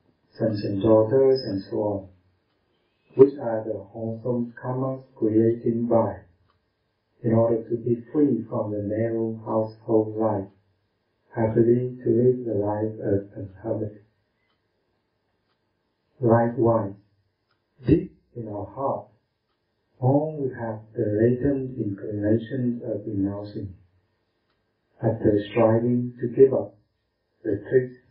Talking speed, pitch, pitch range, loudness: 110 wpm, 110 Hz, 105-120 Hz, -24 LUFS